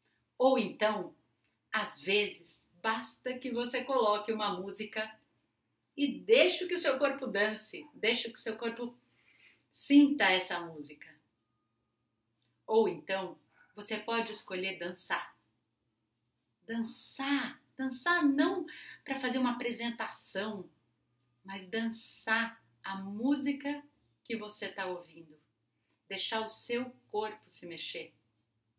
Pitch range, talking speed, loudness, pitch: 175-250 Hz, 110 wpm, -33 LUFS, 215 Hz